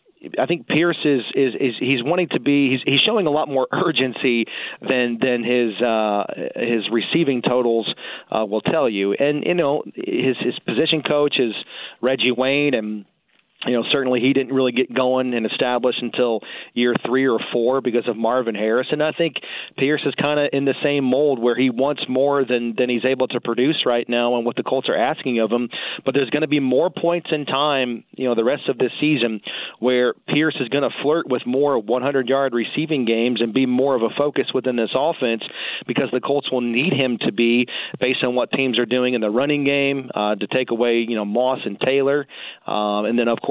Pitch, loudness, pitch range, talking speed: 130 Hz, -20 LUFS, 120-140 Hz, 215 wpm